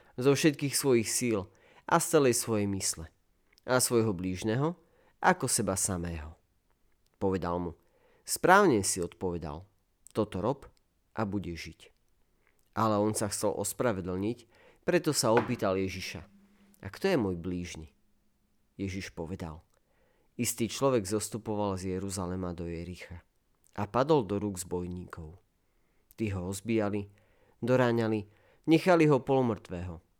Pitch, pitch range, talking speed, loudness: 100 Hz, 90-120 Hz, 120 wpm, -30 LUFS